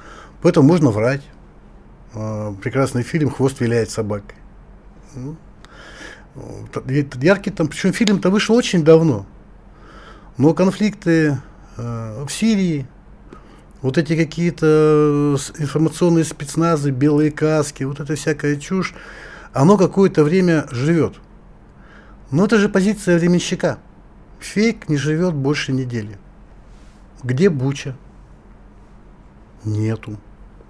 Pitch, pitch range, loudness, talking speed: 150 Hz, 130-175 Hz, -18 LUFS, 95 wpm